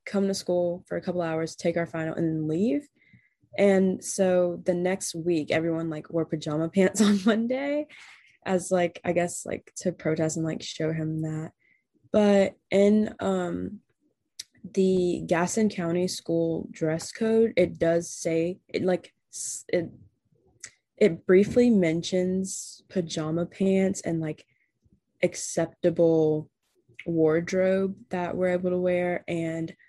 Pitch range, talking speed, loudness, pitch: 165-190 Hz, 135 wpm, -26 LUFS, 180 Hz